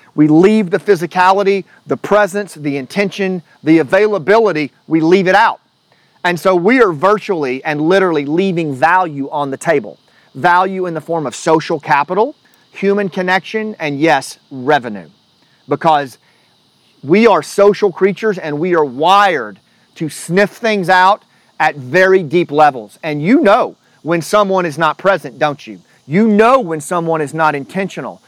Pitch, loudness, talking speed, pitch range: 175 Hz, -13 LUFS, 155 wpm, 155-195 Hz